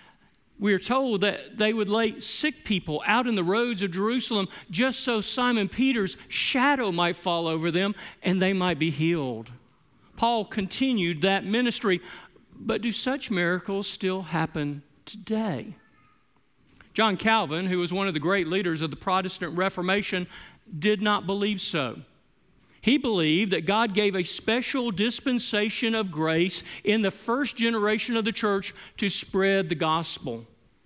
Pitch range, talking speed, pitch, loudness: 175-225 Hz, 150 wpm, 200 Hz, -26 LUFS